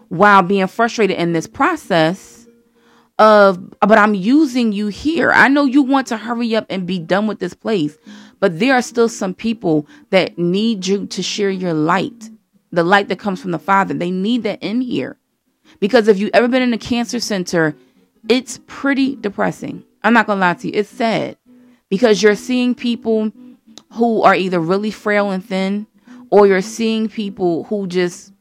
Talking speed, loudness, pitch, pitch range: 185 wpm, -16 LUFS, 210 Hz, 190-235 Hz